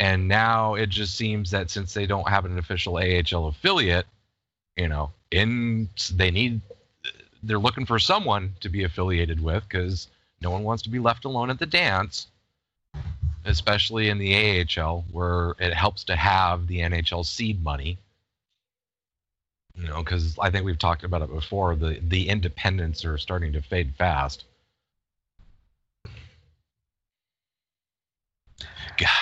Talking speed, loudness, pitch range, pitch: 145 wpm, -24 LUFS, 85-105 Hz, 90 Hz